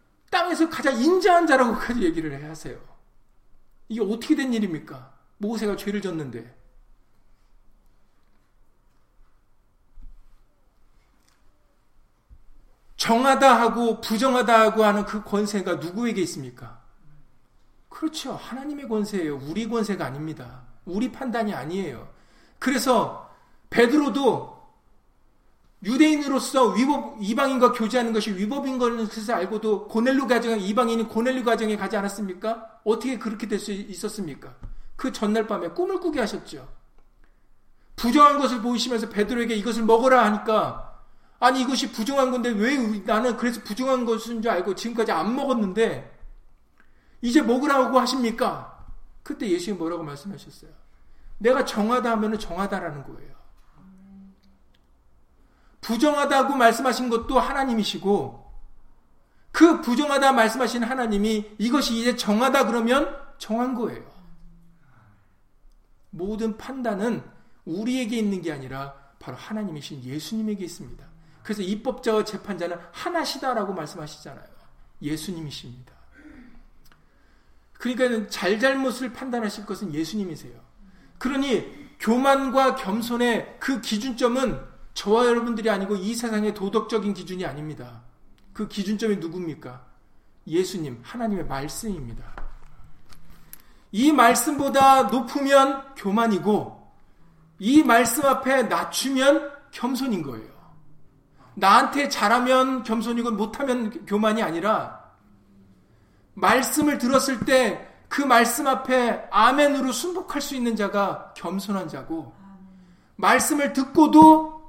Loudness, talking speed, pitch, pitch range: -23 LUFS, 280 characters per minute, 225 Hz, 185-255 Hz